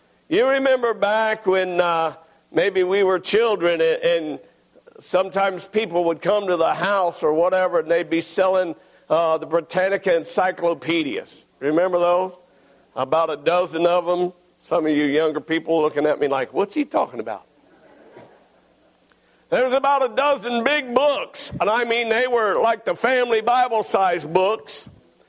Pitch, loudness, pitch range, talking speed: 185 Hz, -20 LUFS, 165-230 Hz, 155 wpm